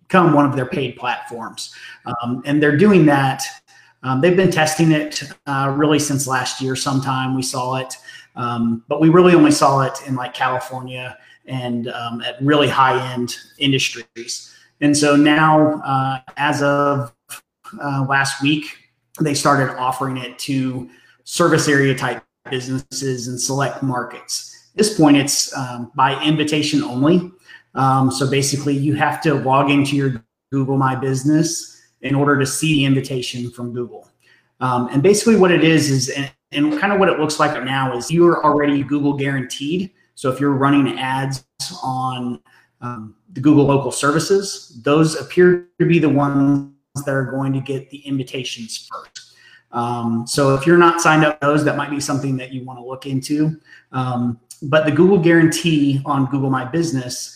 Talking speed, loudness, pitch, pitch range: 175 wpm, -17 LUFS, 140 Hz, 130-150 Hz